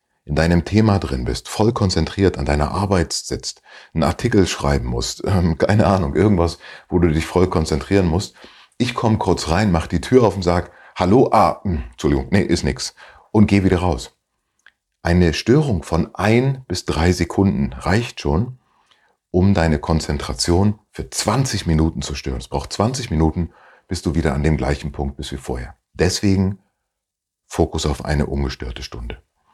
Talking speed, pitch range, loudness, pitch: 170 wpm, 75-100 Hz, -19 LUFS, 85 Hz